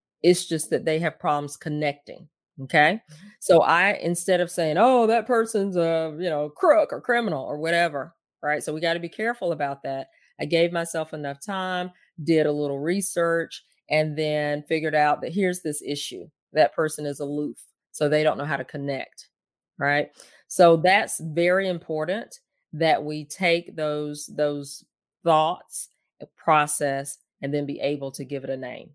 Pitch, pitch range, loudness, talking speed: 155 Hz, 145-175 Hz, -24 LUFS, 170 wpm